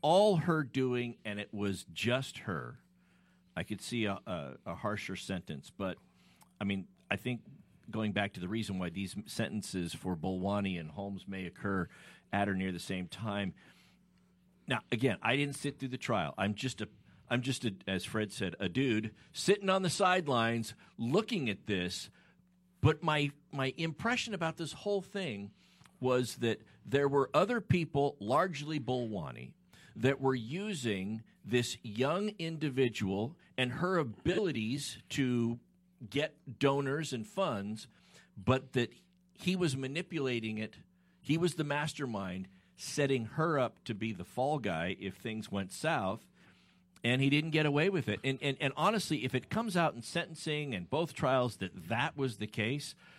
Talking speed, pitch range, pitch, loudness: 160 wpm, 105-155 Hz, 130 Hz, -35 LUFS